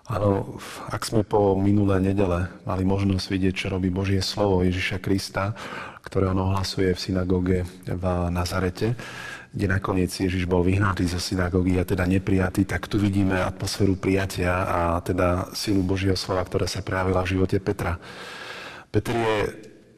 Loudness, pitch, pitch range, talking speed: -24 LUFS, 95 Hz, 90-100 Hz, 150 wpm